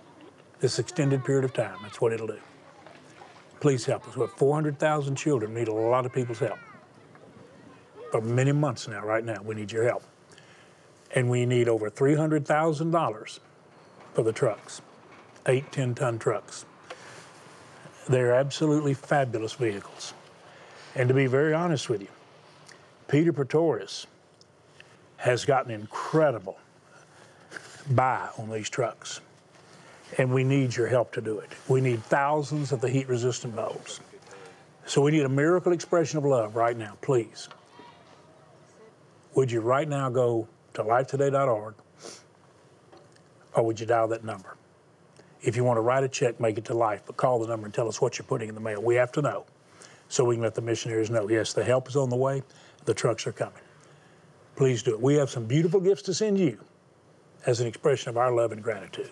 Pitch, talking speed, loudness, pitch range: 130 Hz, 170 wpm, -27 LUFS, 115-145 Hz